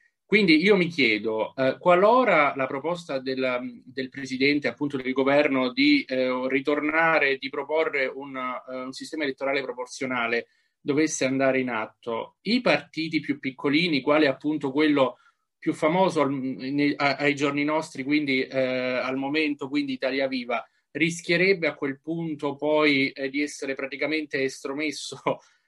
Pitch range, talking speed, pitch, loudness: 135-155 Hz, 145 wpm, 145 Hz, -24 LUFS